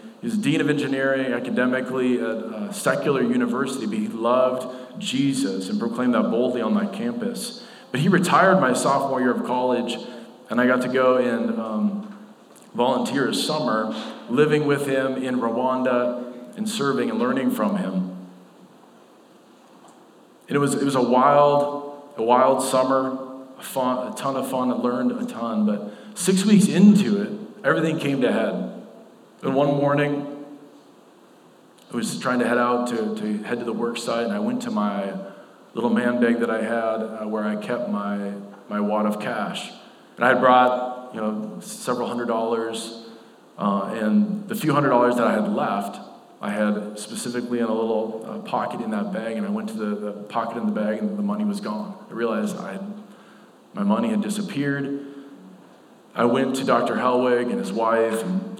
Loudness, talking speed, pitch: -23 LUFS, 180 wpm, 130 Hz